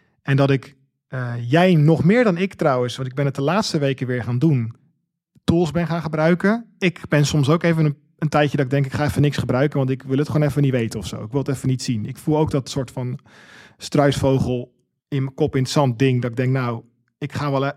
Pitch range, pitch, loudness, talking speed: 130-155 Hz, 140 Hz, -20 LUFS, 265 wpm